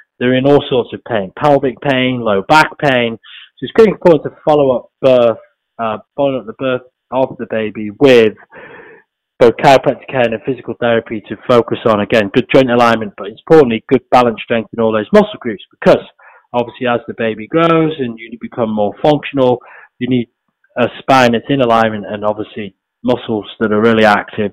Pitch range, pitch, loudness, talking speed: 110-135 Hz, 120 Hz, -13 LUFS, 190 wpm